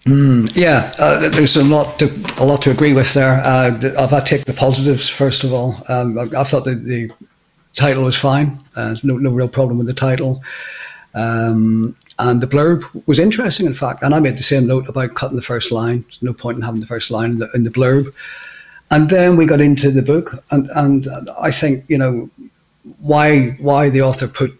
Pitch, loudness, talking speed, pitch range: 135 Hz, -14 LUFS, 220 wpm, 125-145 Hz